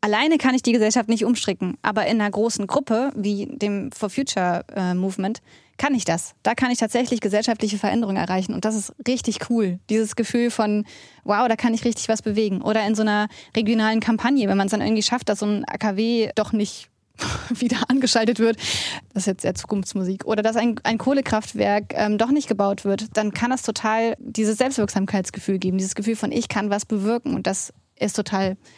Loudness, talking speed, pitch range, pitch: -22 LUFS, 200 wpm, 205-235 Hz, 215 Hz